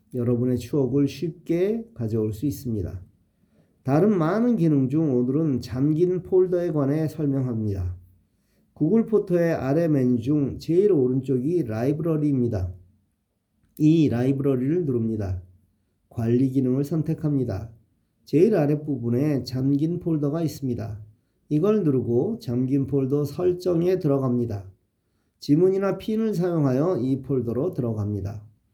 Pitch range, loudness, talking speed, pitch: 115-155 Hz, -23 LUFS, 285 characters per minute, 135 Hz